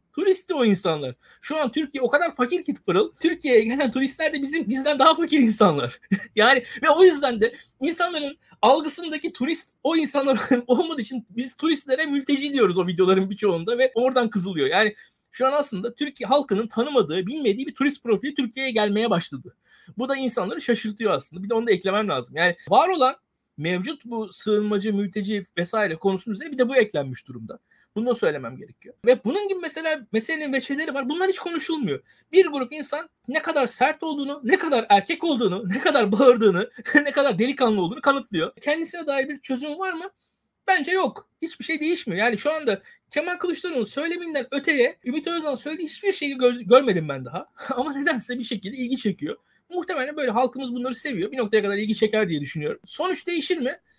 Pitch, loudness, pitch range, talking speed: 260 Hz, -23 LUFS, 215-310 Hz, 180 wpm